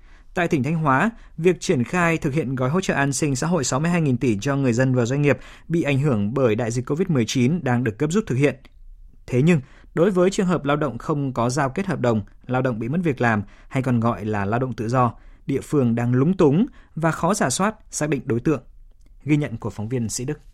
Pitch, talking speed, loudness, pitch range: 135 Hz, 250 wpm, -22 LUFS, 120-165 Hz